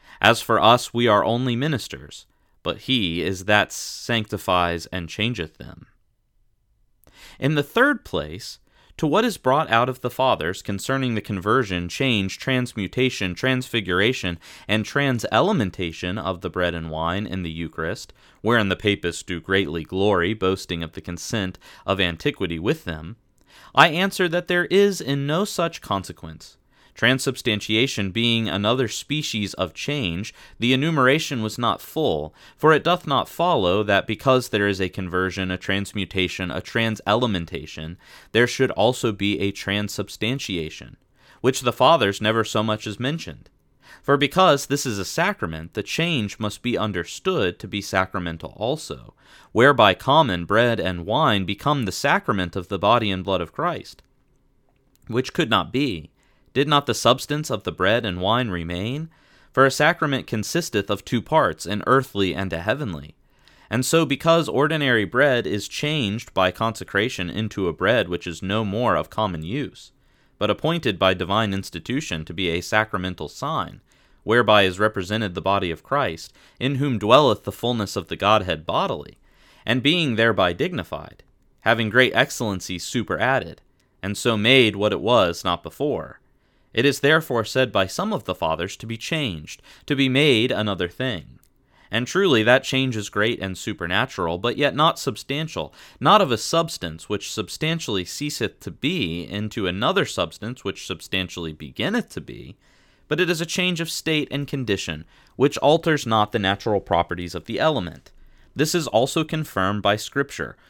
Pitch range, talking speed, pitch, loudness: 95-130 Hz, 160 wpm, 110 Hz, -22 LUFS